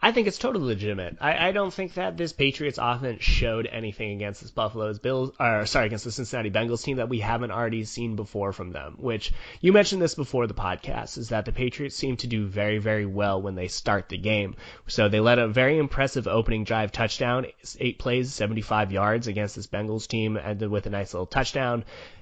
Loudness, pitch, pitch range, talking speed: -26 LUFS, 115 Hz, 105-130 Hz, 215 wpm